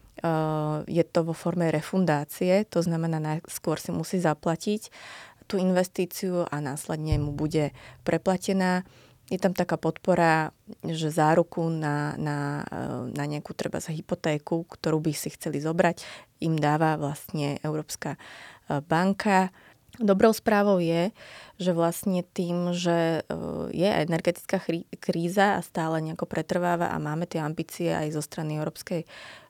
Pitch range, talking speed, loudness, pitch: 155-180 Hz, 130 wpm, -27 LUFS, 165 Hz